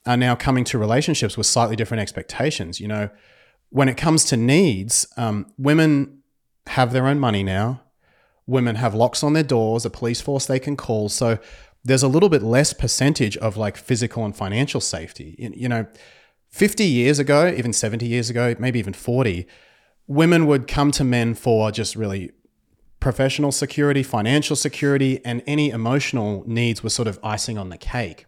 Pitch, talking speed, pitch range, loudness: 120 Hz, 175 wpm, 110-140 Hz, -20 LUFS